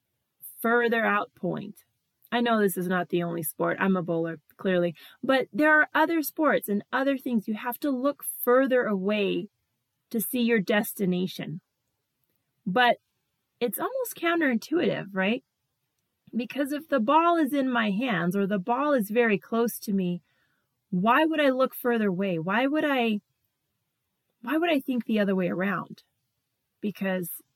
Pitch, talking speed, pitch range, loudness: 220 Hz, 155 wpm, 180-260 Hz, -26 LUFS